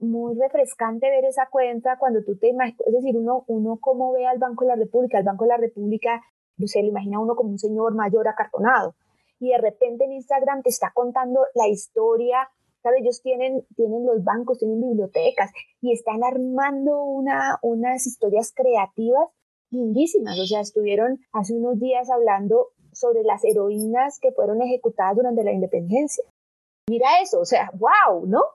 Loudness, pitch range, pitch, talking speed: -22 LUFS, 225-260 Hz, 245 Hz, 175 wpm